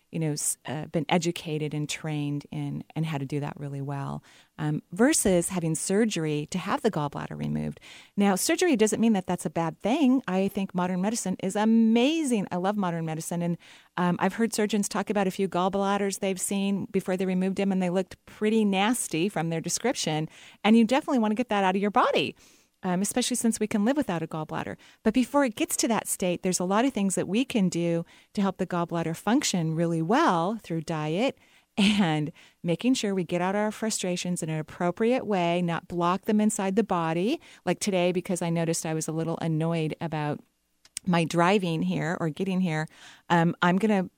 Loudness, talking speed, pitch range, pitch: -27 LUFS, 205 wpm, 165-210 Hz, 185 Hz